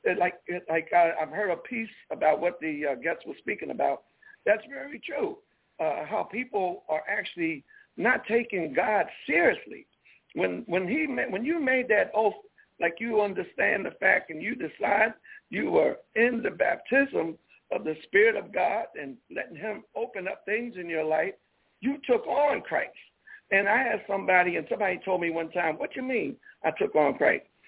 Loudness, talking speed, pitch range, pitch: -27 LUFS, 180 wpm, 175-260 Hz, 210 Hz